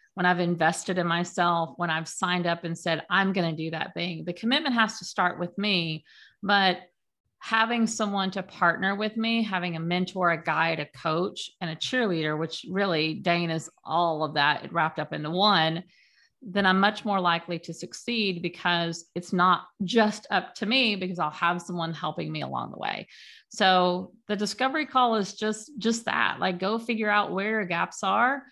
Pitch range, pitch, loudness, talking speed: 170-210 Hz, 180 Hz, -26 LUFS, 190 wpm